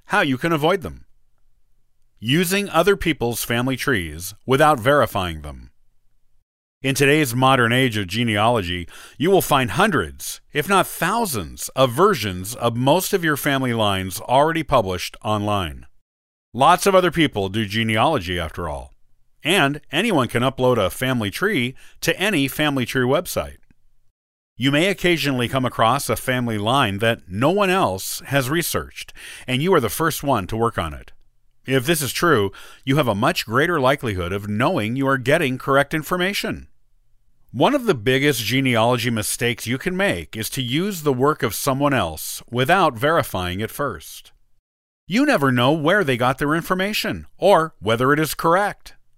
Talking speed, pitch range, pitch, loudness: 160 wpm, 105-145 Hz, 130 Hz, -20 LUFS